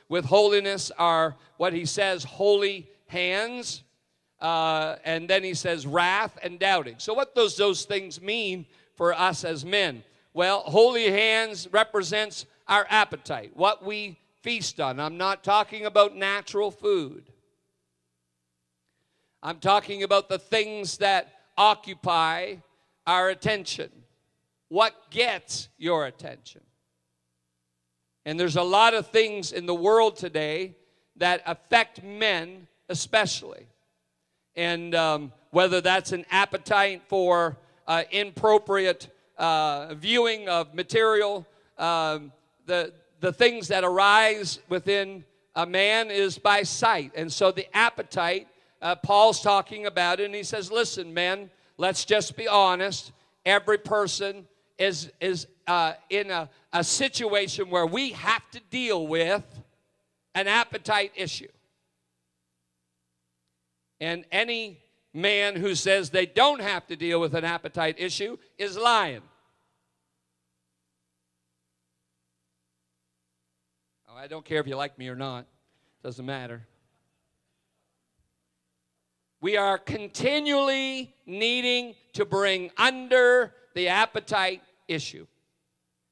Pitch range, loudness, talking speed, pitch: 145-205 Hz, -25 LUFS, 120 wpm, 180 Hz